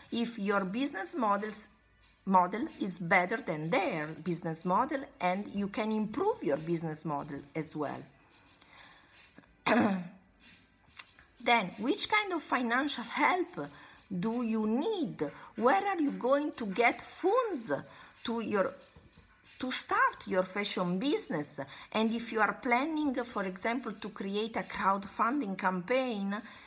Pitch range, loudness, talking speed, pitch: 185-255 Hz, -32 LUFS, 125 wpm, 215 Hz